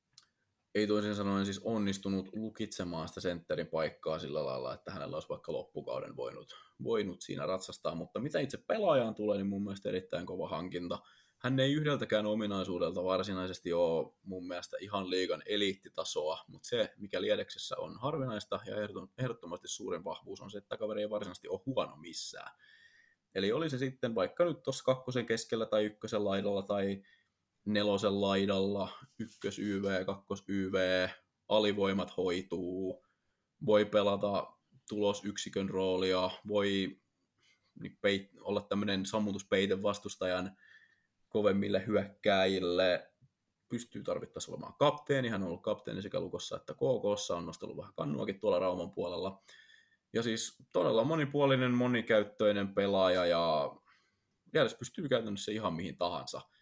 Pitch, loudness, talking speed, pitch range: 105 Hz, -35 LUFS, 130 wpm, 95-125 Hz